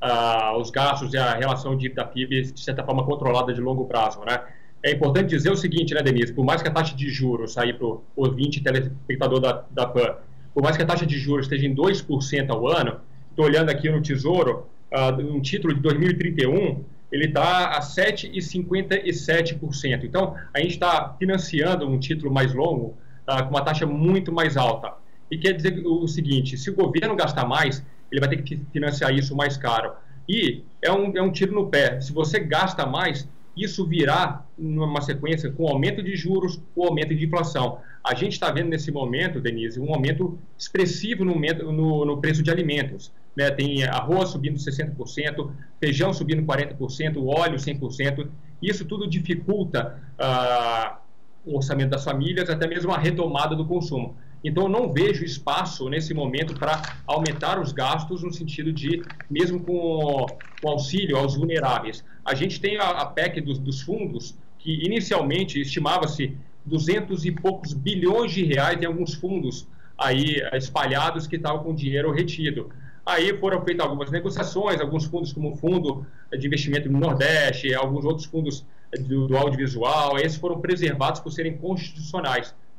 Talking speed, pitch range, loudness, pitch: 170 wpm, 135-170 Hz, -24 LUFS, 150 Hz